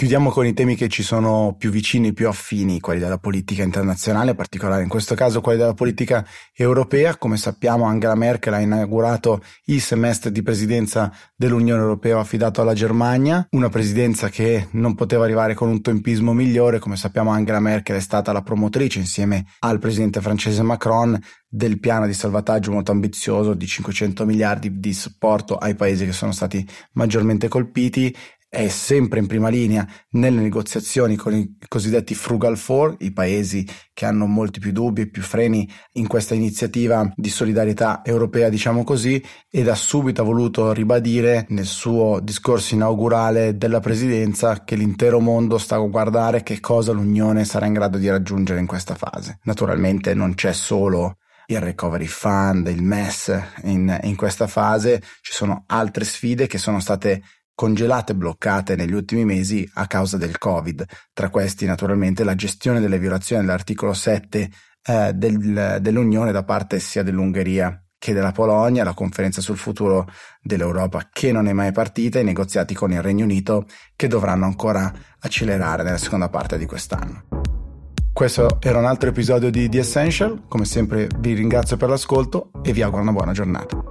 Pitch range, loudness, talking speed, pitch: 100-115 Hz, -20 LUFS, 165 wpm, 110 Hz